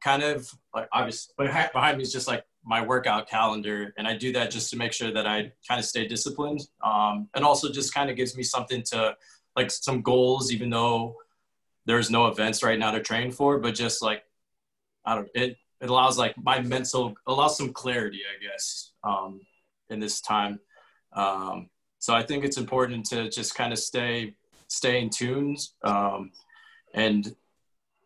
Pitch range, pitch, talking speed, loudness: 110-130 Hz, 120 Hz, 185 wpm, -26 LUFS